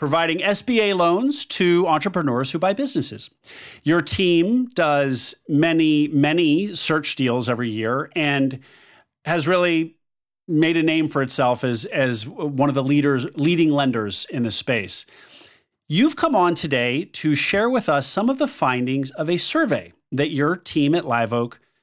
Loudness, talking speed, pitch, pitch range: -20 LUFS, 155 wpm, 155 Hz, 135-180 Hz